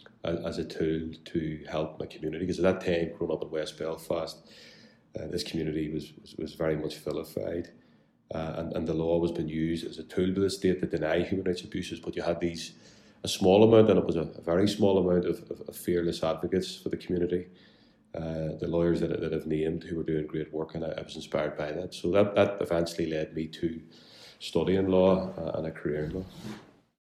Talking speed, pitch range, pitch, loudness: 230 wpm, 80-90 Hz, 85 Hz, -29 LUFS